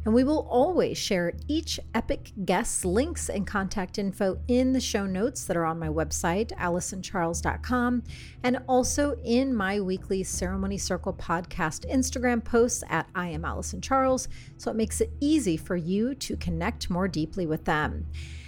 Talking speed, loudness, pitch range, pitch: 160 wpm, -28 LUFS, 170-255 Hz, 200 Hz